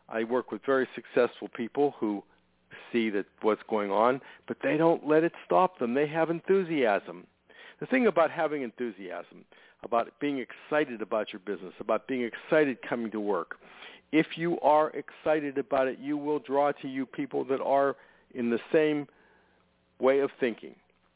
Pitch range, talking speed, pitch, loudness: 120-155 Hz, 165 wpm, 140 Hz, -29 LUFS